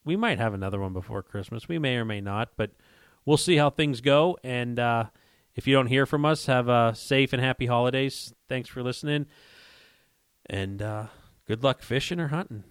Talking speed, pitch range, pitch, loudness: 200 wpm, 110-140 Hz, 125 Hz, -26 LUFS